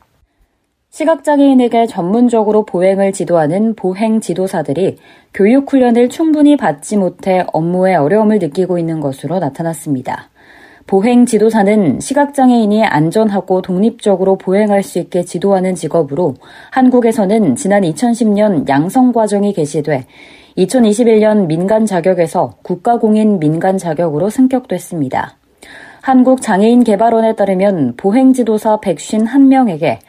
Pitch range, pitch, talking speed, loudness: 180-230 Hz, 205 Hz, 310 characters per minute, -12 LUFS